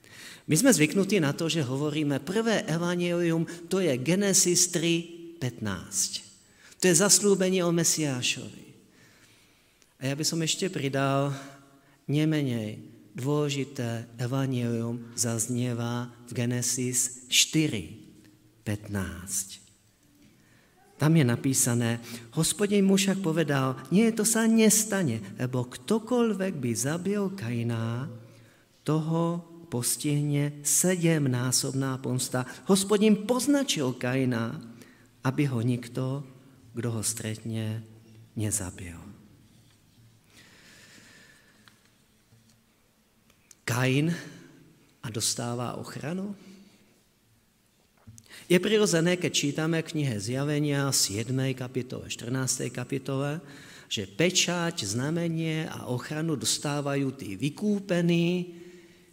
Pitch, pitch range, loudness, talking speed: 135 Hz, 120-170 Hz, -27 LUFS, 85 wpm